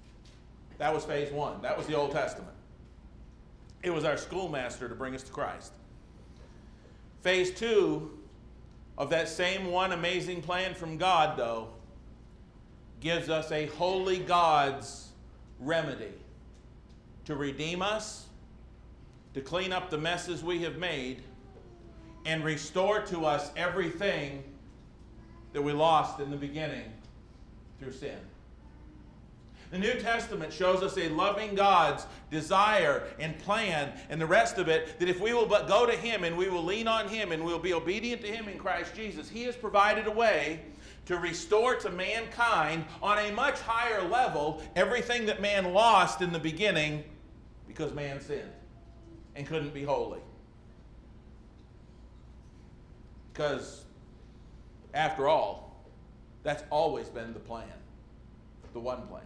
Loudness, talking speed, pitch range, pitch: -30 LUFS, 140 wpm, 145-195 Hz, 165 Hz